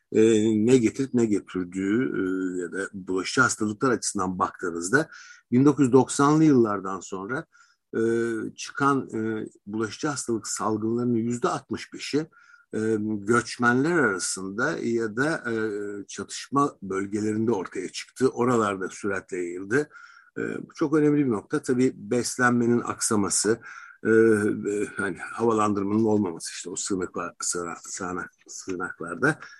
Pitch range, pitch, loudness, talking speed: 105-135 Hz, 115 Hz, -25 LUFS, 110 wpm